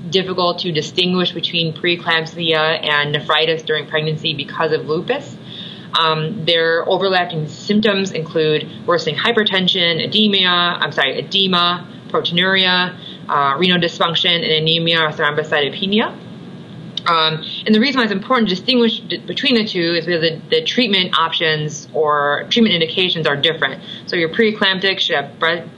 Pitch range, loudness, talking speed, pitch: 160-195 Hz, -16 LUFS, 140 wpm, 175 Hz